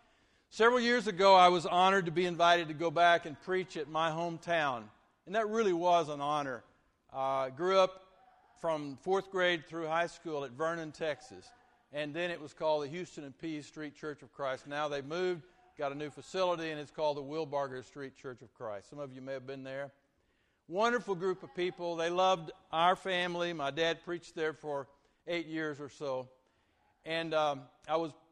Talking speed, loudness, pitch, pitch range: 195 wpm, -33 LUFS, 160 Hz, 145-180 Hz